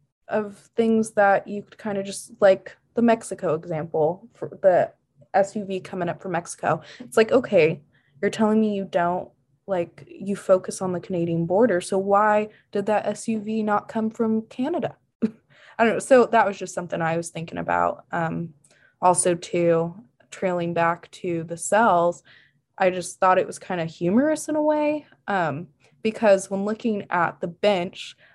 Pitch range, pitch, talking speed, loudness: 170-220 Hz, 195 Hz, 170 wpm, -23 LUFS